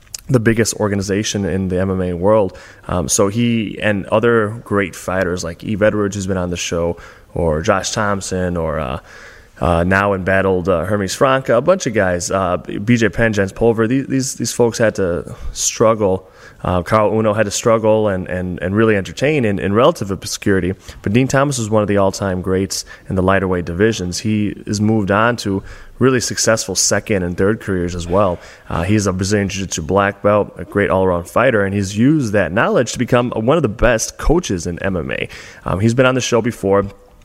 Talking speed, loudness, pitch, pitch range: 200 wpm, -16 LUFS, 100 Hz, 95-110 Hz